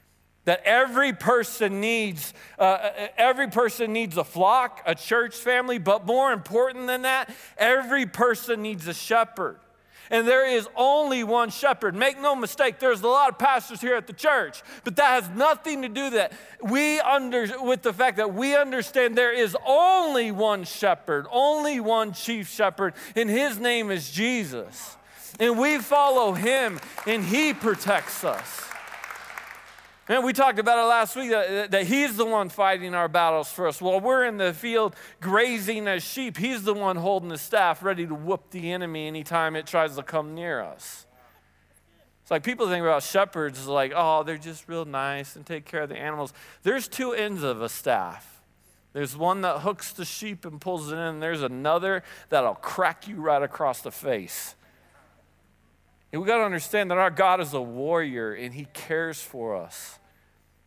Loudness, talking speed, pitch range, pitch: -24 LUFS, 180 wpm, 165-250 Hz, 210 Hz